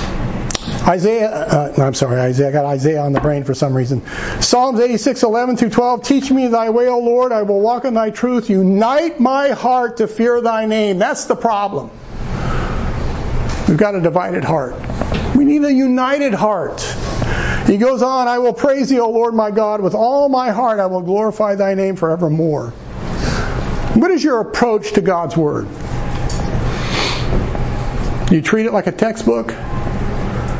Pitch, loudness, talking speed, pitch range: 220 Hz, -16 LUFS, 165 wpm, 175-245 Hz